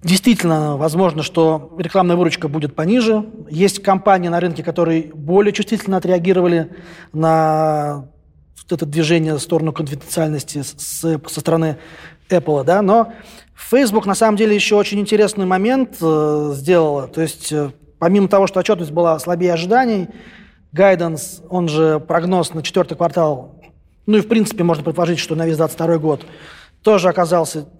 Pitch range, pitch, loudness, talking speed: 160-195 Hz, 170 Hz, -16 LUFS, 140 wpm